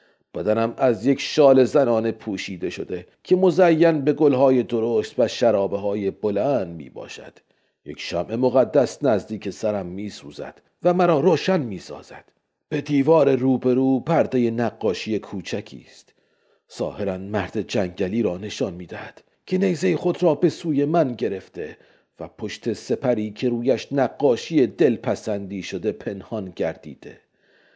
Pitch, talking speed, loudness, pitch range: 125 Hz, 130 wpm, -22 LUFS, 105-150 Hz